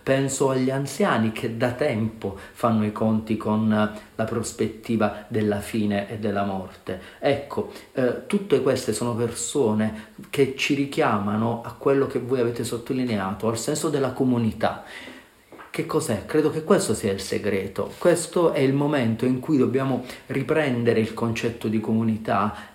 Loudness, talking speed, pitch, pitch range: -24 LUFS, 150 wpm, 115 Hz, 110-135 Hz